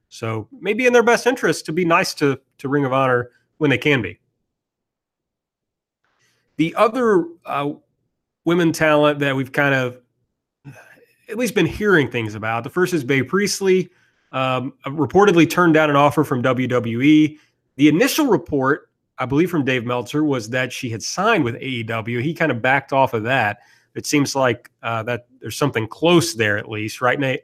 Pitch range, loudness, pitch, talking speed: 125-160 Hz, -19 LUFS, 140 Hz, 175 wpm